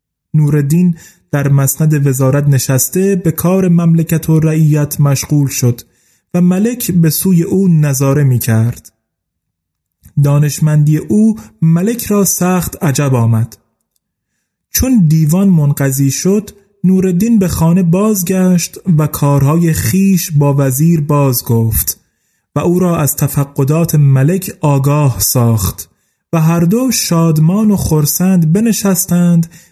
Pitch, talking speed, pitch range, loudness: 155 Hz, 115 wpm, 140-180 Hz, -12 LUFS